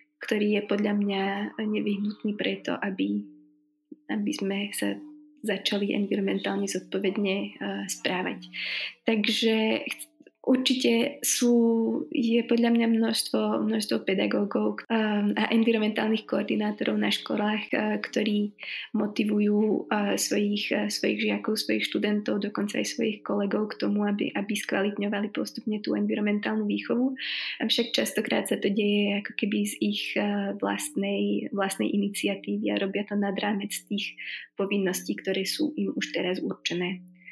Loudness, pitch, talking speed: -27 LUFS, 205 Hz, 120 wpm